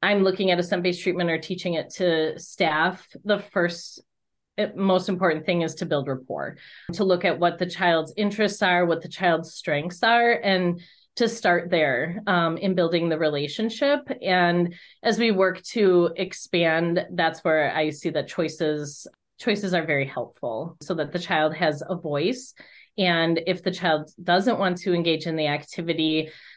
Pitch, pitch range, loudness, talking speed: 175 Hz, 160-190 Hz, -24 LUFS, 170 wpm